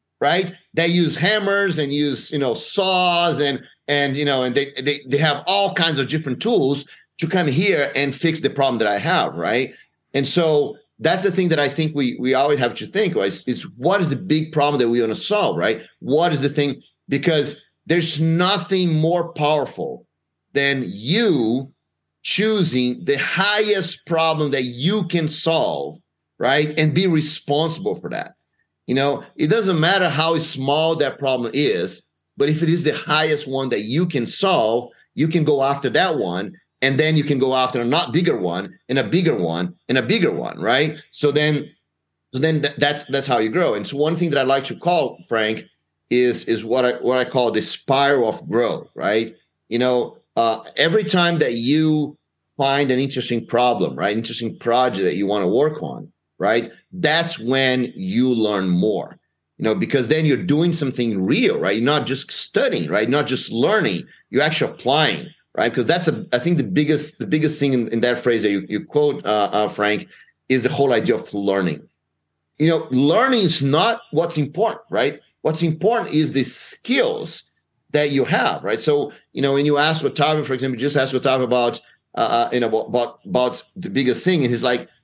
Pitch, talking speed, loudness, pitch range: 145 Hz, 200 wpm, -19 LUFS, 125-160 Hz